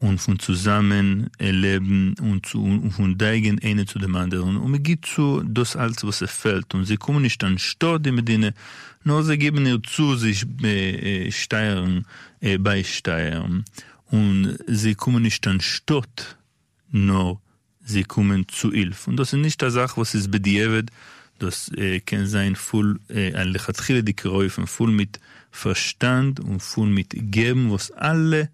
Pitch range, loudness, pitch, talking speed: 95-120 Hz, -22 LUFS, 105 Hz, 165 wpm